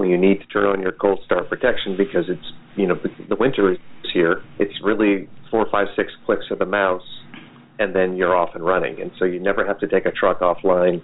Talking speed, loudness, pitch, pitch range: 235 wpm, -20 LUFS, 95 Hz, 90-100 Hz